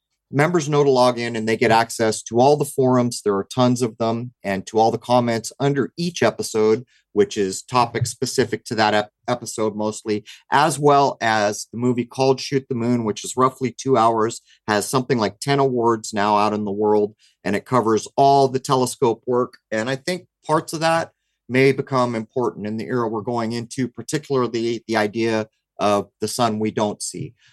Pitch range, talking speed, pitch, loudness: 110-130 Hz, 195 wpm, 120 Hz, -20 LUFS